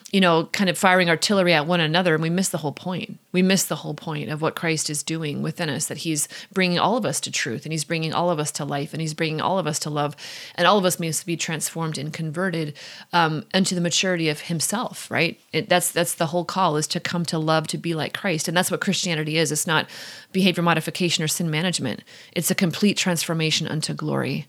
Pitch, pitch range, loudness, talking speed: 170 Hz, 155-180 Hz, -22 LUFS, 245 wpm